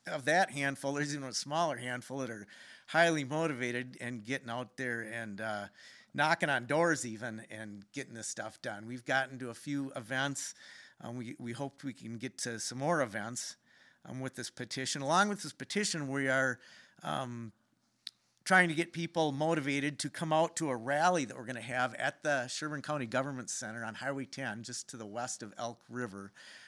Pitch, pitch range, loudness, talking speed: 130 Hz, 120-145 Hz, -35 LUFS, 200 wpm